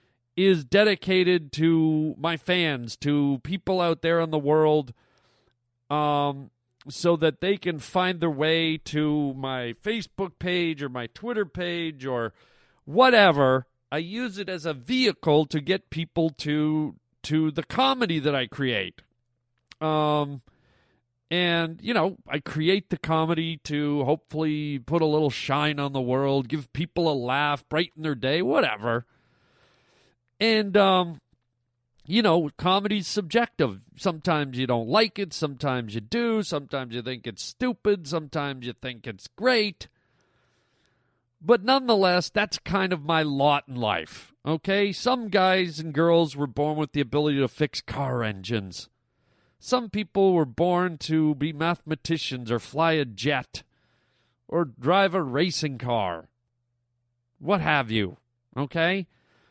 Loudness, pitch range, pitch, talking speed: -25 LUFS, 130-180 Hz, 155 Hz, 140 wpm